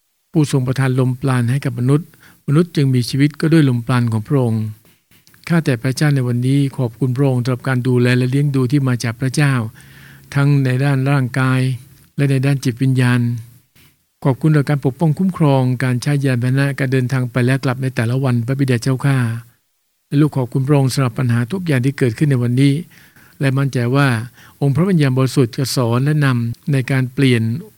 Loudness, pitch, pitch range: -17 LUFS, 135 Hz, 125-140 Hz